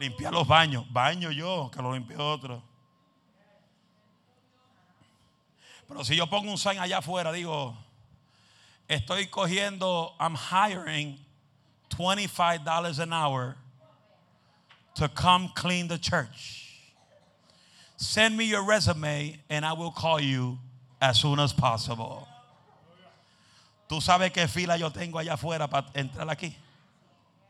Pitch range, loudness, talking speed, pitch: 135-175 Hz, -27 LUFS, 120 wpm, 150 Hz